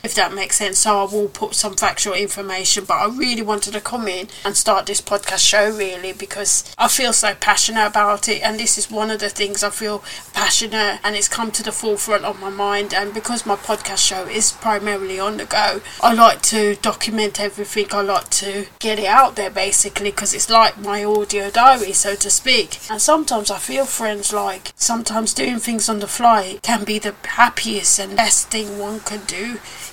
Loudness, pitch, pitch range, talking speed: -17 LUFS, 210 Hz, 200-220 Hz, 210 wpm